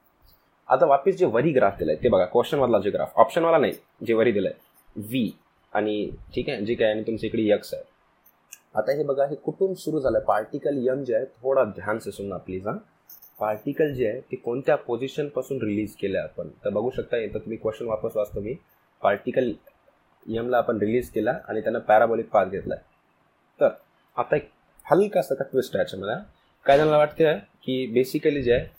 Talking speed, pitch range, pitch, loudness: 180 wpm, 110-150 Hz, 130 Hz, -24 LUFS